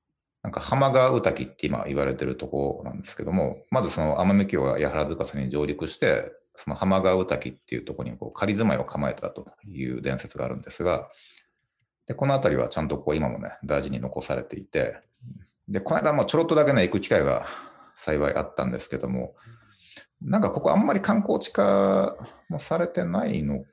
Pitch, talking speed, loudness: 95 Hz, 385 characters per minute, -26 LUFS